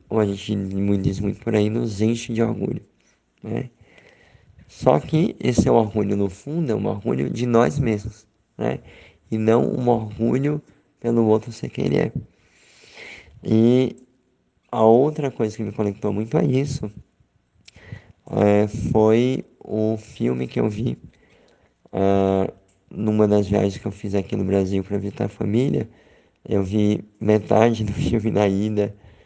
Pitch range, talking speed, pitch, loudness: 100-115 Hz, 150 wpm, 110 Hz, -21 LUFS